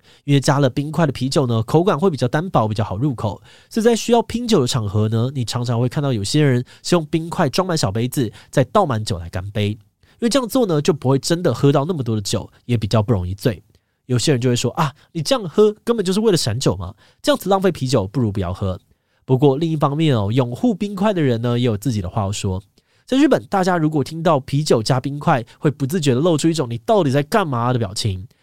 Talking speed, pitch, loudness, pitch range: 355 characters per minute, 135 Hz, -19 LUFS, 115-165 Hz